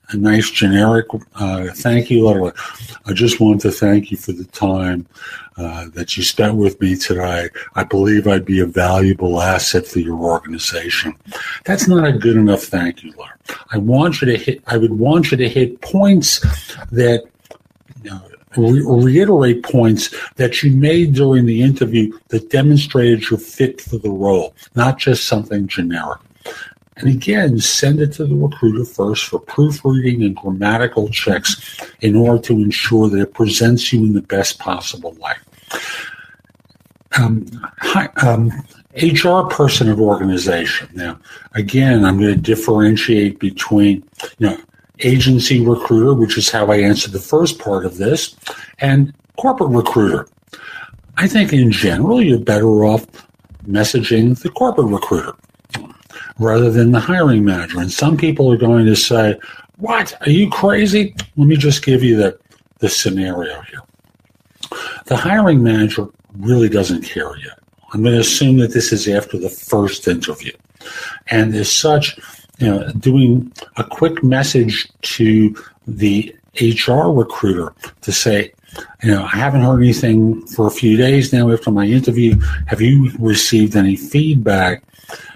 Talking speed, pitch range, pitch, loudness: 155 wpm, 105-130 Hz, 115 Hz, -14 LUFS